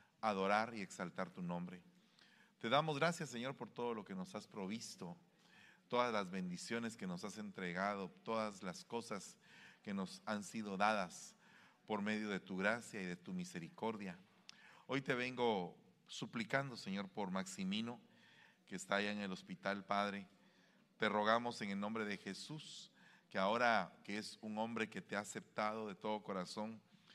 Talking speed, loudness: 165 wpm, -42 LUFS